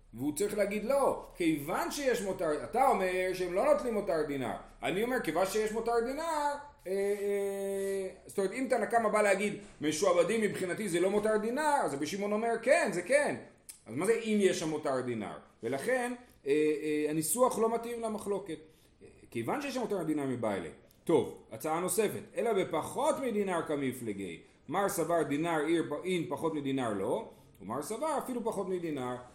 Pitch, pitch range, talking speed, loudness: 200 Hz, 160-235 Hz, 170 wpm, -32 LUFS